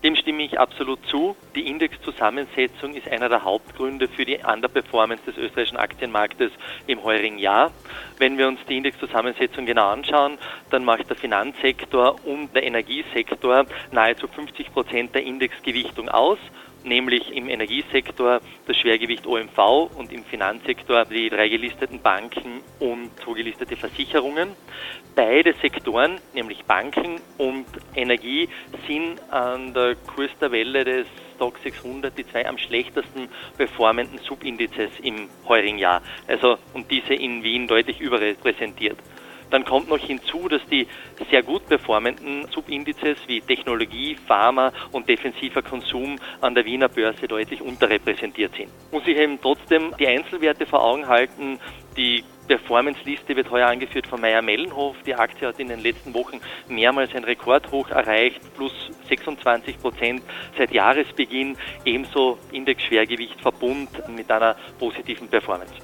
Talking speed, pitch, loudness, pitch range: 135 wpm, 130 Hz, -22 LUFS, 120-140 Hz